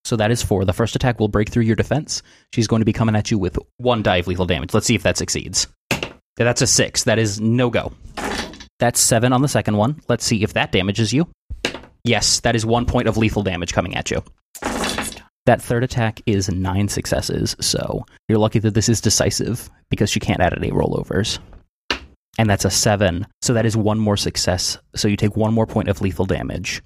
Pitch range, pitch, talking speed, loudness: 100-120 Hz, 110 Hz, 220 wpm, -19 LUFS